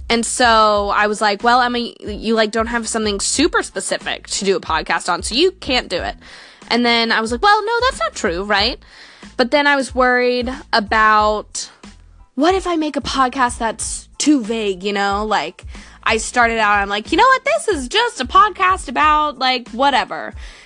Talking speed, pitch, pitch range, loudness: 205 wpm, 245 Hz, 220-300 Hz, -16 LUFS